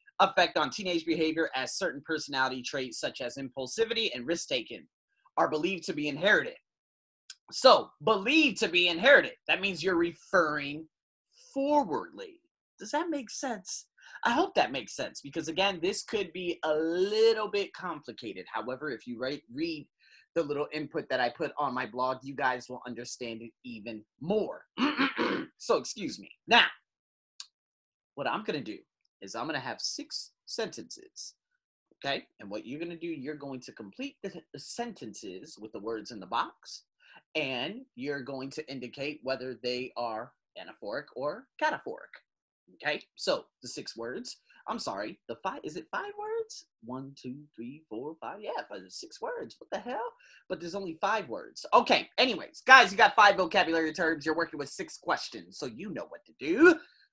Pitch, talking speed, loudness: 175 Hz, 170 wpm, -30 LUFS